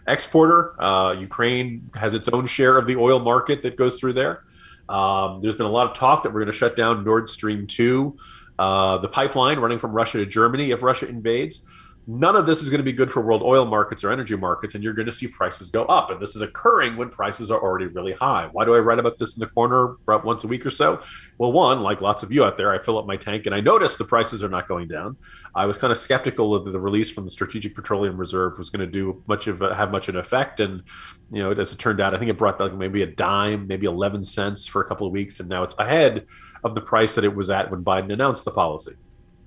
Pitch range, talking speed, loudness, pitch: 100-125 Hz, 270 wpm, -21 LUFS, 110 Hz